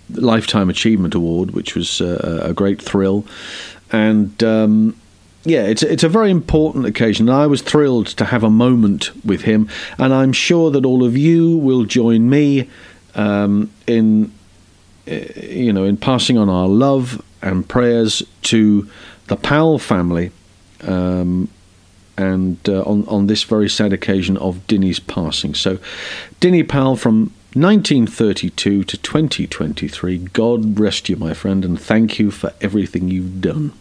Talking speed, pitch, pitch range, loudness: 155 wpm, 110 Hz, 95-125 Hz, -15 LUFS